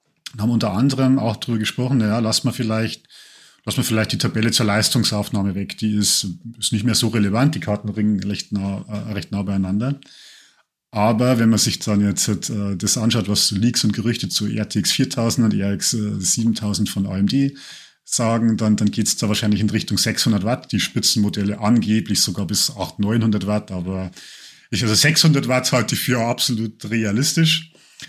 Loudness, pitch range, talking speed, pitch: -19 LUFS, 105-120 Hz, 175 wpm, 110 Hz